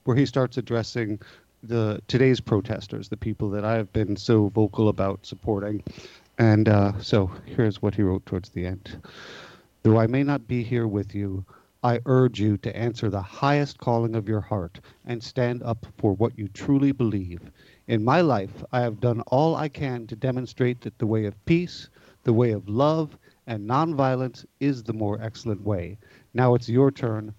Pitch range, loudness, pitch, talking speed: 105-130 Hz, -25 LUFS, 115 Hz, 185 wpm